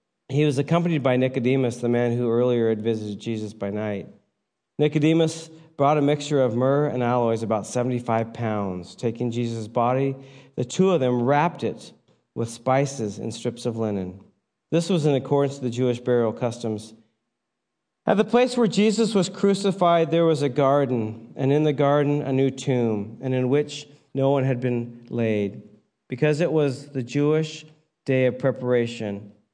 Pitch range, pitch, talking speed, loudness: 115-150 Hz, 130 Hz, 170 wpm, -23 LUFS